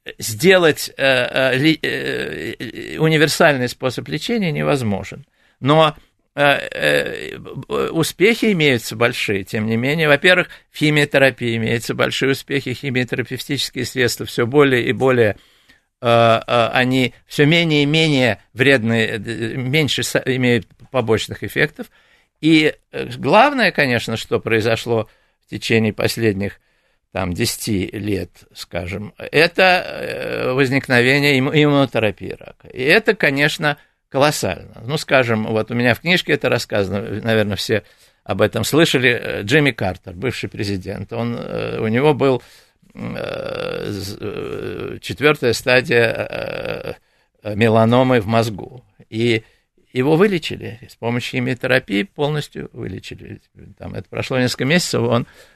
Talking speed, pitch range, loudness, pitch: 105 wpm, 115-145 Hz, -17 LUFS, 125 Hz